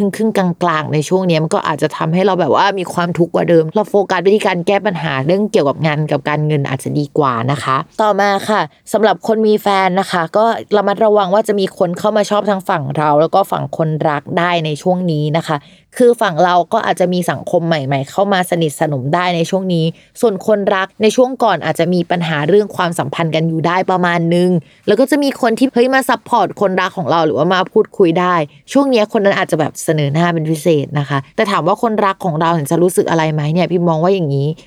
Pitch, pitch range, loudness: 180 Hz, 160-205 Hz, -14 LUFS